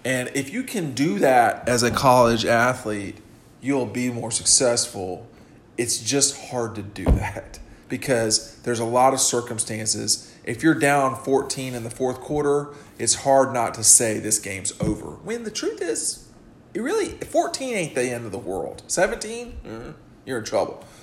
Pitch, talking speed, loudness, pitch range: 125 Hz, 170 wpm, -22 LUFS, 115-140 Hz